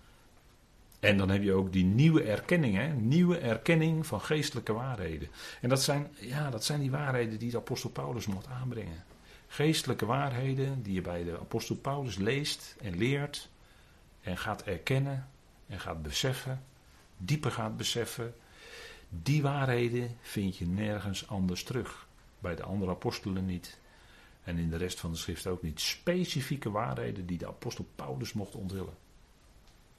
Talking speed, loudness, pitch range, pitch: 155 wpm, -33 LUFS, 95-135 Hz, 115 Hz